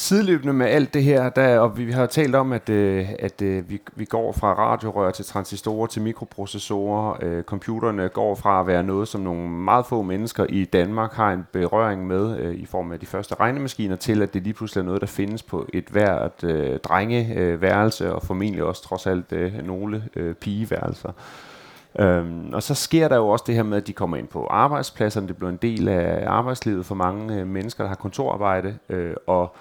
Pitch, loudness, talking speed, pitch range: 100 Hz, -23 LUFS, 210 wpm, 95-115 Hz